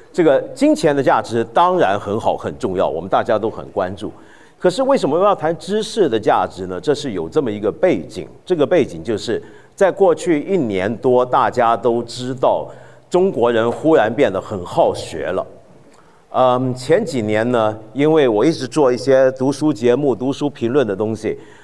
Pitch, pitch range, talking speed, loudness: 130 Hz, 120-165 Hz, 265 characters per minute, -17 LUFS